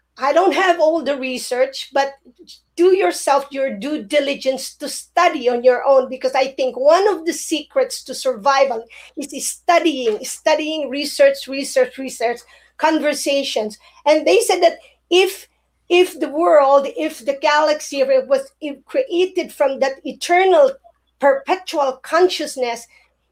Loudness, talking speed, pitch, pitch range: -17 LUFS, 135 wpm, 285 Hz, 270-330 Hz